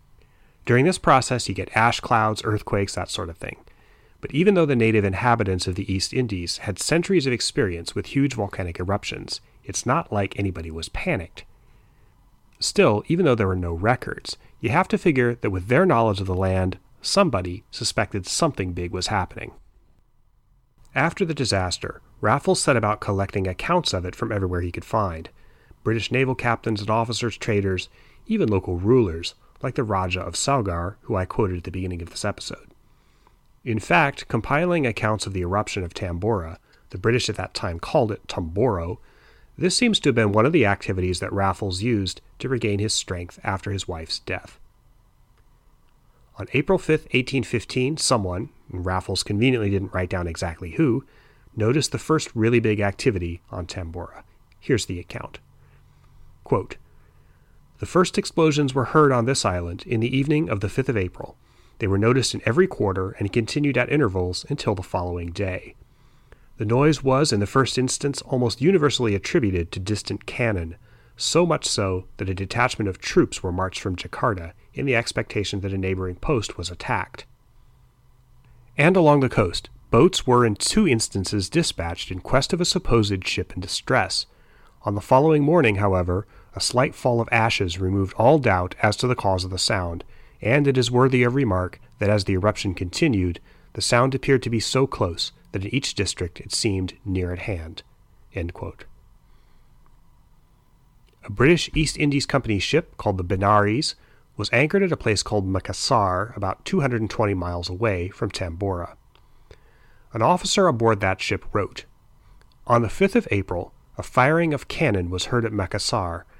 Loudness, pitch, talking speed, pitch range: -23 LUFS, 110 Hz, 175 wpm, 95-130 Hz